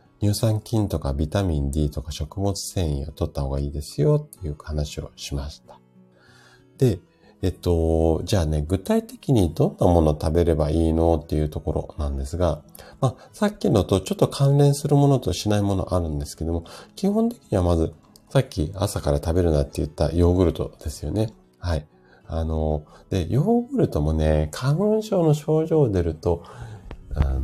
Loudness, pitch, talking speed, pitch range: -23 LUFS, 85 Hz, 335 characters per minute, 75-105 Hz